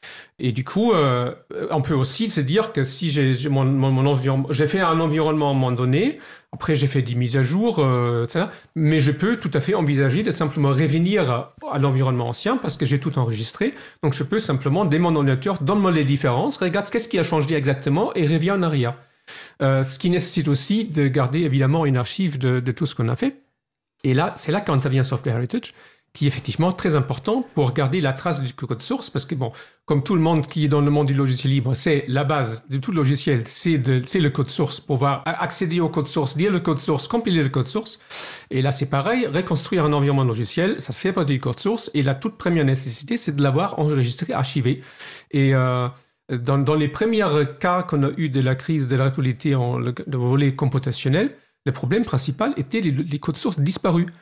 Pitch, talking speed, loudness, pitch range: 145 Hz, 220 wpm, -21 LUFS, 135-165 Hz